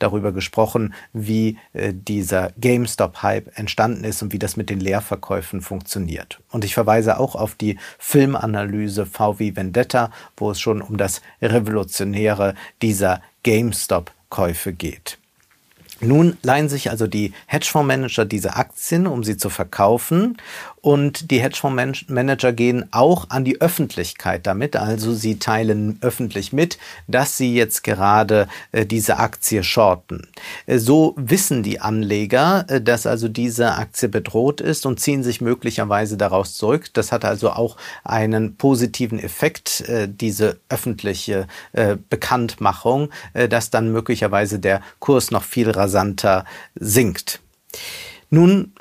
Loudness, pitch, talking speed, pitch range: -19 LUFS, 110 Hz, 135 wpm, 105-125 Hz